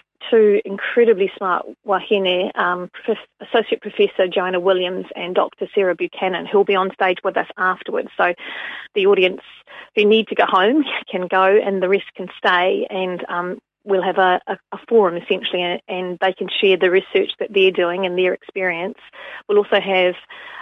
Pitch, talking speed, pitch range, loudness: 190 Hz, 180 wpm, 185-215 Hz, -18 LUFS